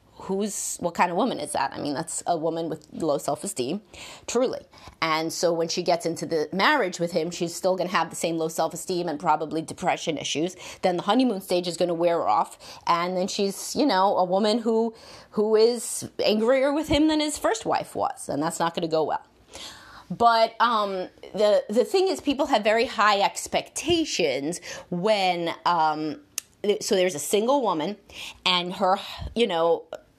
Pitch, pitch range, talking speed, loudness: 185 Hz, 165-225 Hz, 190 wpm, -25 LUFS